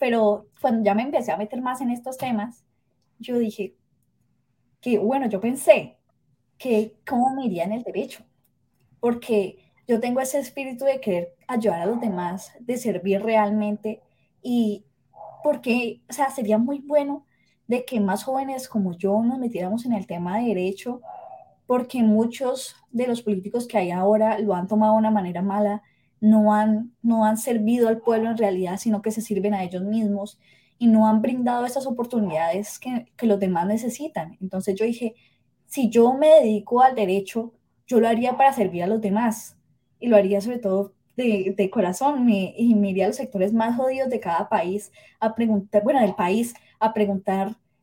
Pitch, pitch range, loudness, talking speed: 220 Hz, 205-245 Hz, -23 LUFS, 180 wpm